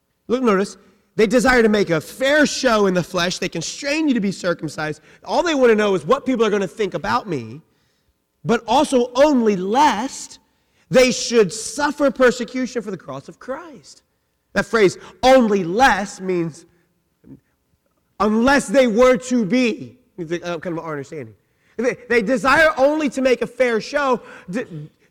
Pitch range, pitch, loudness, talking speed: 175-255 Hz, 225 Hz, -18 LUFS, 160 wpm